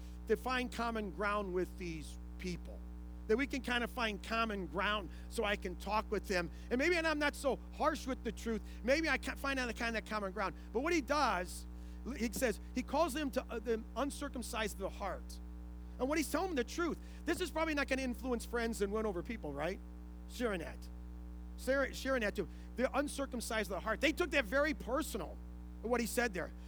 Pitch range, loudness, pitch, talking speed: 175-265 Hz, -37 LUFS, 225 Hz, 215 wpm